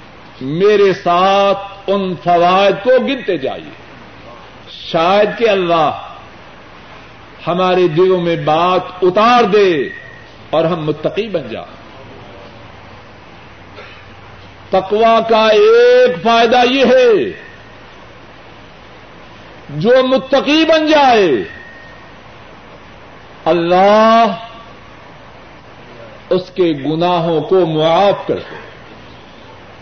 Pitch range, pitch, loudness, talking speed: 160-230 Hz, 190 Hz, -12 LUFS, 75 wpm